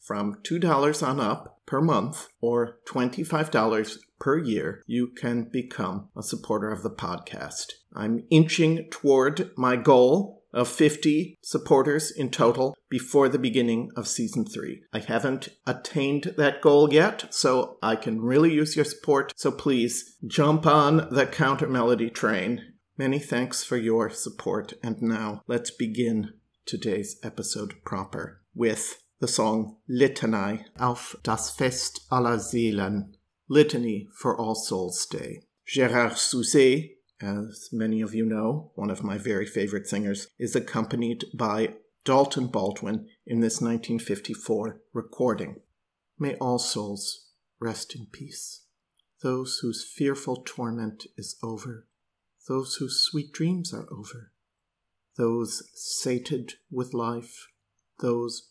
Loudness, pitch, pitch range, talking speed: -26 LUFS, 120 Hz, 110-140 Hz, 130 wpm